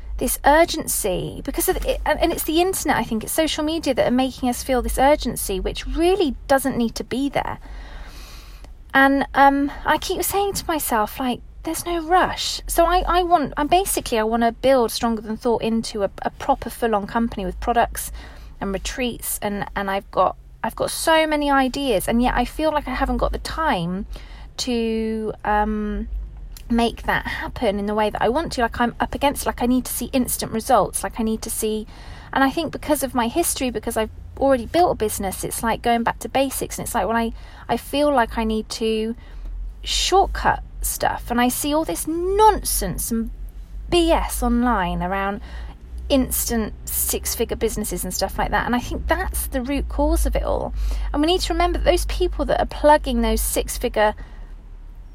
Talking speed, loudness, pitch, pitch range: 200 wpm, -21 LUFS, 250 Hz, 225-300 Hz